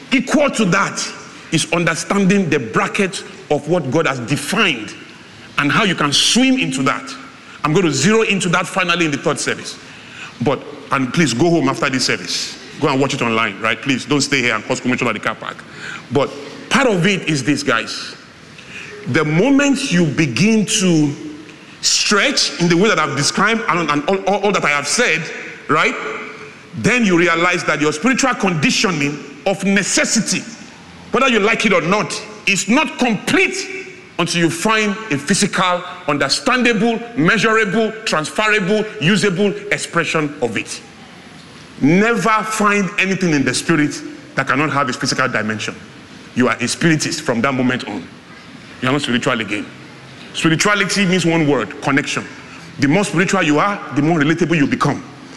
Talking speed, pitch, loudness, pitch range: 170 wpm, 175 Hz, -16 LUFS, 145-210 Hz